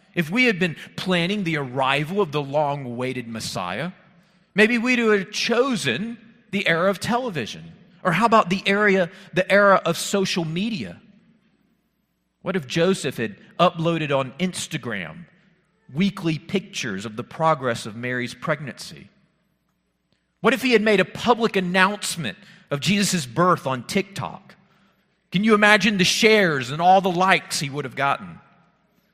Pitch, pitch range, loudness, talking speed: 185 Hz, 165-205 Hz, -21 LUFS, 145 wpm